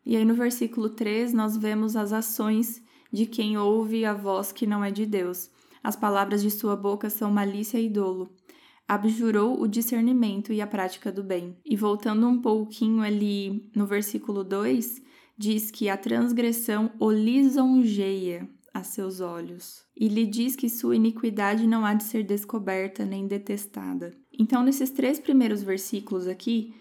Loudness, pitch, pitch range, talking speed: -26 LUFS, 215 Hz, 200-230 Hz, 160 wpm